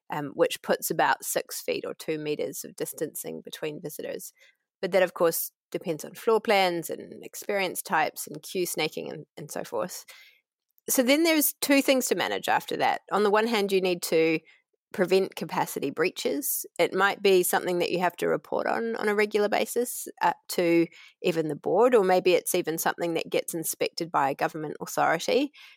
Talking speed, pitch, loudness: 190 wpm, 210 Hz, -26 LUFS